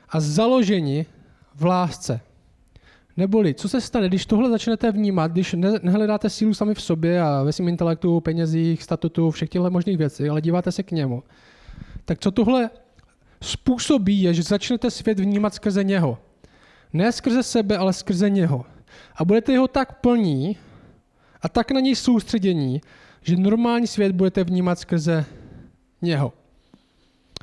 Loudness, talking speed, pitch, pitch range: -21 LUFS, 150 wpm, 185 Hz, 160-215 Hz